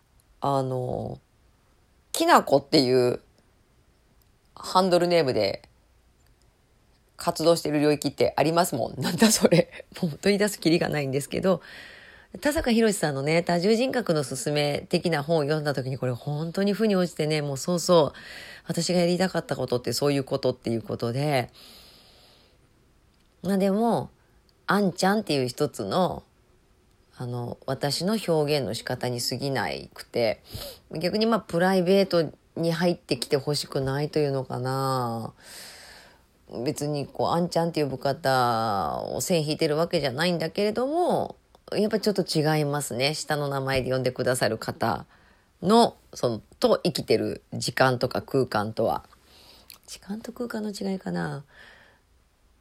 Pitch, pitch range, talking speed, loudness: 150 Hz, 130-180 Hz, 300 characters per minute, -25 LUFS